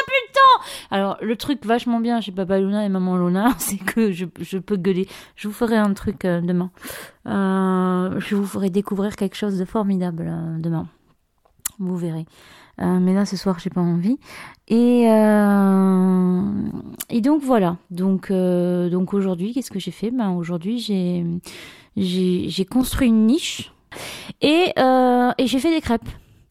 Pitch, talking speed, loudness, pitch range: 195 Hz, 155 wpm, -20 LUFS, 185-230 Hz